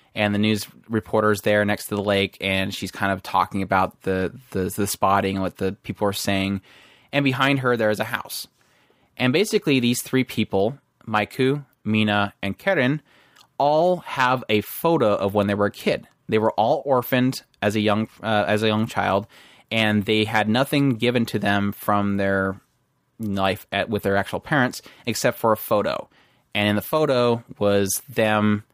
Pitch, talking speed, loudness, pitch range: 105 Hz, 185 wpm, -22 LUFS, 100-120 Hz